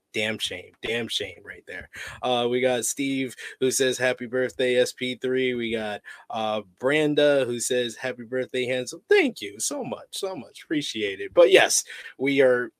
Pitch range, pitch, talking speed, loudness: 125-150 Hz, 130 Hz, 170 wpm, -24 LUFS